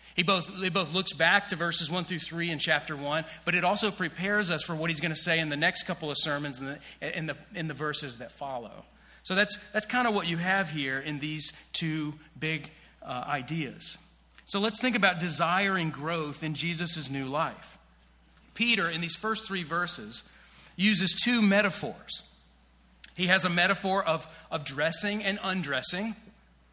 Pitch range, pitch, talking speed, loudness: 150-190 Hz, 170 Hz, 190 wpm, -28 LUFS